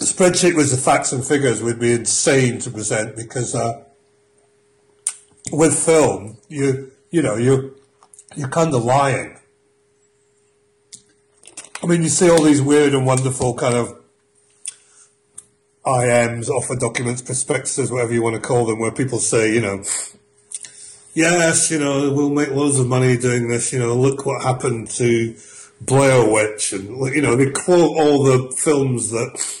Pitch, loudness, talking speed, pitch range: 135 Hz, -17 LUFS, 155 wpm, 120-140 Hz